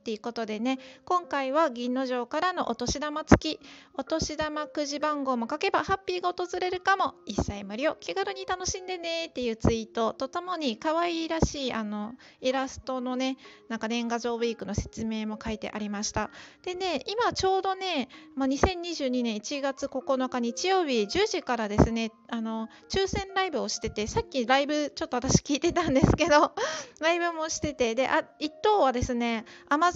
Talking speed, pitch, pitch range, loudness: 345 characters per minute, 280 Hz, 240-345 Hz, -28 LUFS